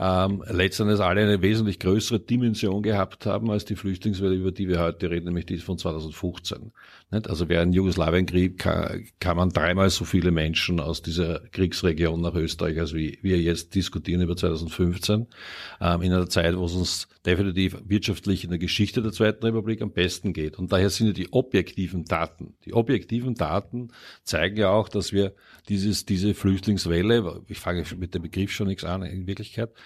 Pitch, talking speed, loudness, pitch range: 95 Hz, 175 wpm, -25 LUFS, 85-105 Hz